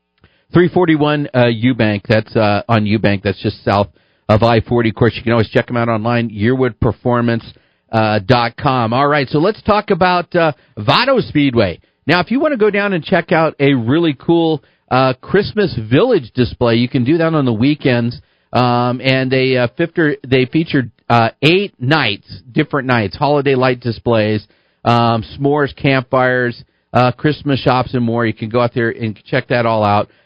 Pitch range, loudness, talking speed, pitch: 115-150 Hz, -15 LUFS, 180 wpm, 125 Hz